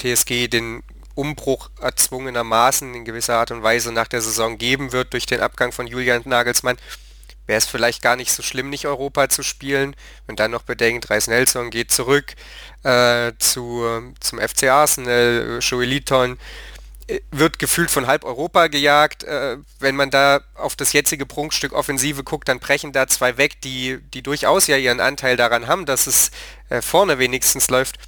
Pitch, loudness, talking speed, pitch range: 130 Hz, -18 LUFS, 170 wpm, 120-140 Hz